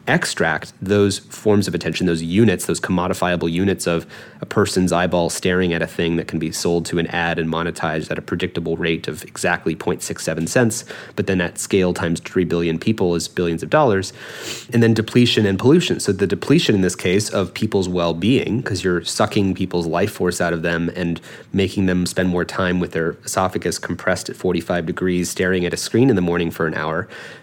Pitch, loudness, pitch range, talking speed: 90 Hz, -19 LUFS, 85-95 Hz, 205 wpm